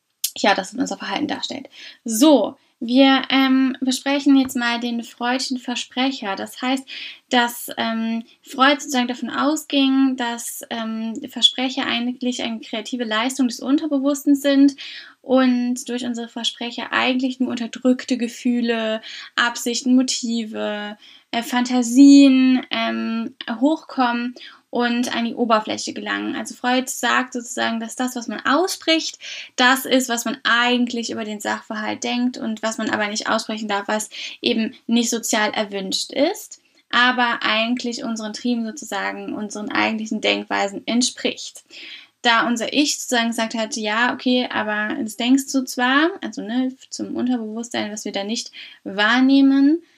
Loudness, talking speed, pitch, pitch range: -20 LUFS, 135 wpm, 245 Hz, 230-265 Hz